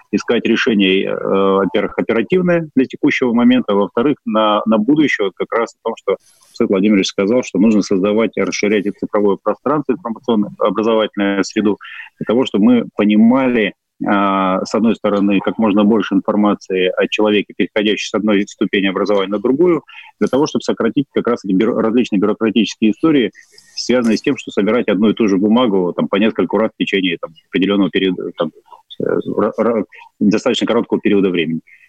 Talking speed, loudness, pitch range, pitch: 165 wpm, -15 LUFS, 100-130 Hz, 105 Hz